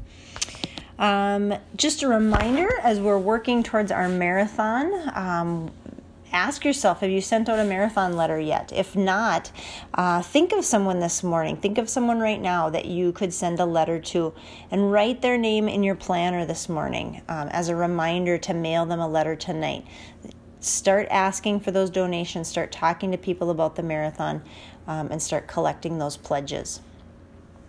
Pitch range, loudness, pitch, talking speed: 165-210 Hz, -24 LUFS, 180 Hz, 170 wpm